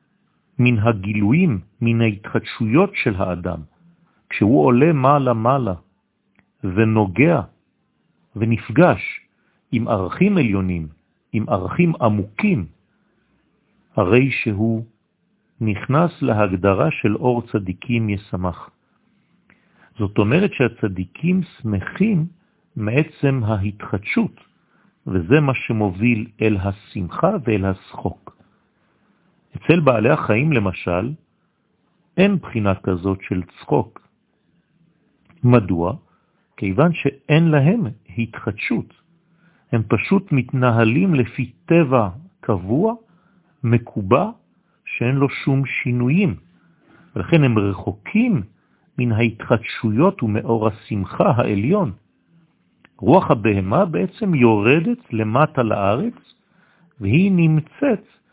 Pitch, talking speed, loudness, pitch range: 120 Hz, 80 wpm, -19 LUFS, 105-170 Hz